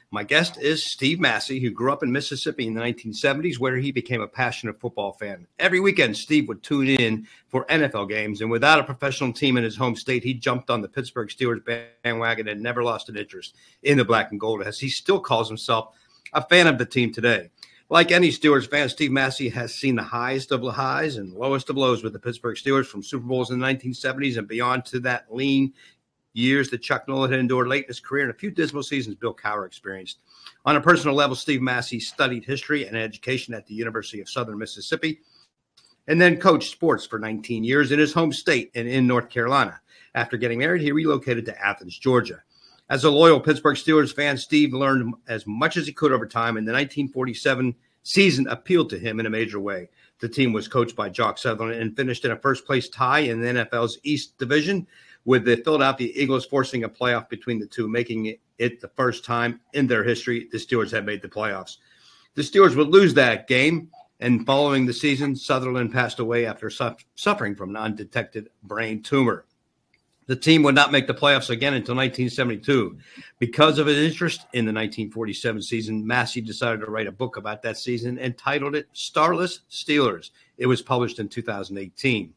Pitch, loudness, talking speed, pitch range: 125 Hz, -22 LUFS, 205 wpm, 115-145 Hz